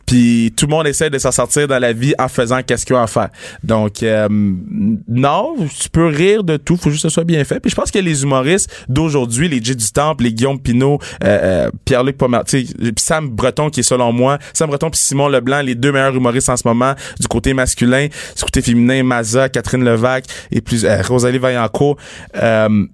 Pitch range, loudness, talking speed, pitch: 120-145 Hz, -14 LUFS, 220 wpm, 130 Hz